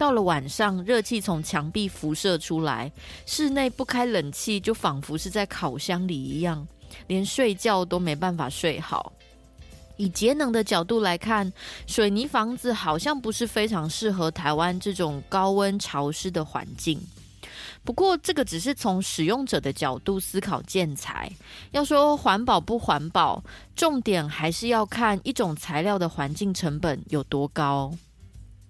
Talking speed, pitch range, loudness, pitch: 230 characters per minute, 160-225 Hz, -25 LUFS, 190 Hz